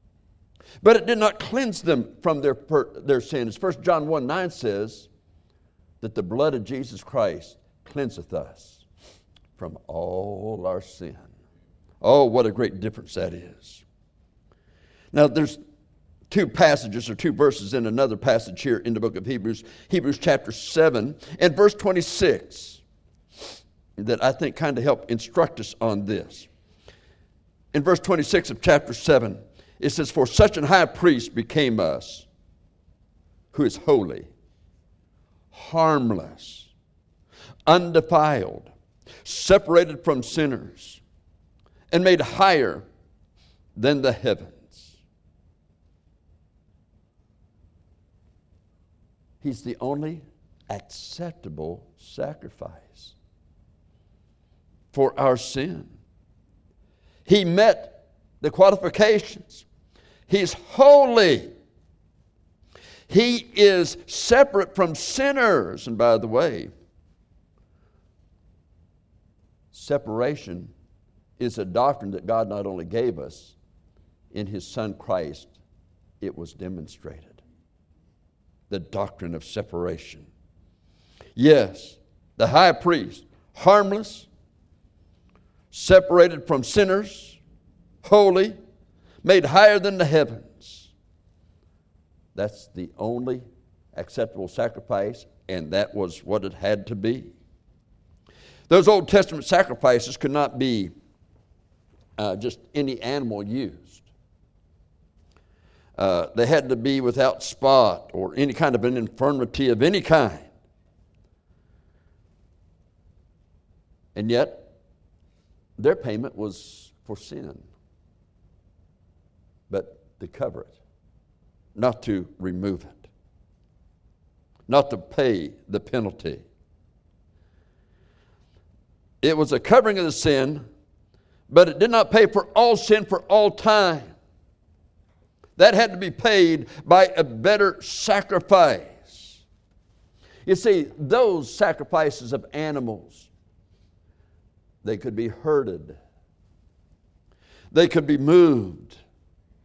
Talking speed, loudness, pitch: 100 wpm, -21 LUFS, 100 Hz